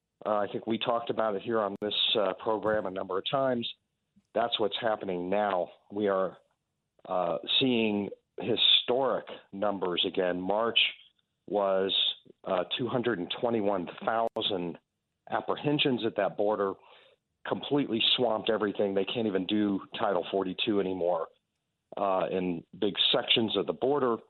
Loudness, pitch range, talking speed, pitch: -29 LUFS, 95-115 Hz, 130 wpm, 105 Hz